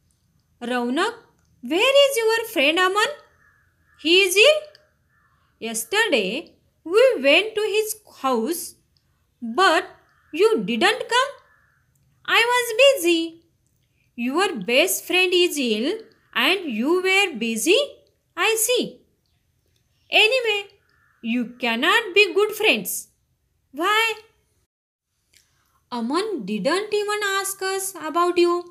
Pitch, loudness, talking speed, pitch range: 370 Hz, -20 LUFS, 100 wpm, 305-430 Hz